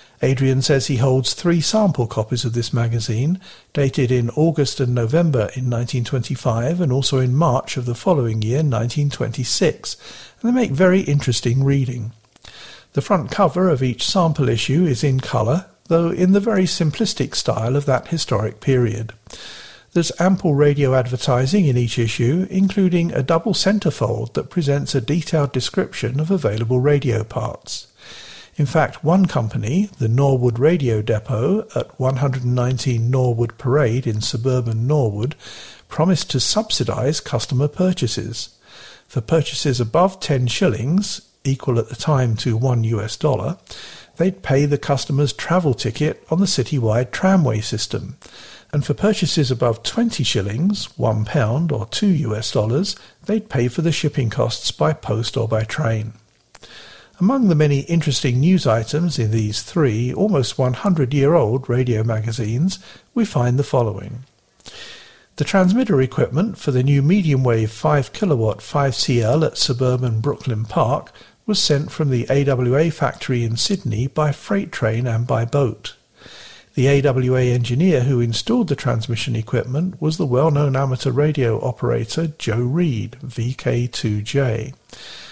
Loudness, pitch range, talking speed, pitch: -19 LUFS, 120-160 Hz, 145 wpm, 135 Hz